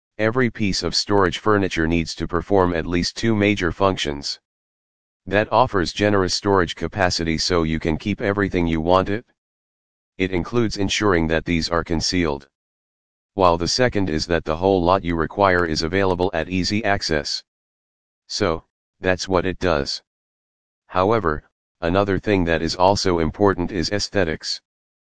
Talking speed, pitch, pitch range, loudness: 150 wpm, 90 Hz, 80-100 Hz, -20 LUFS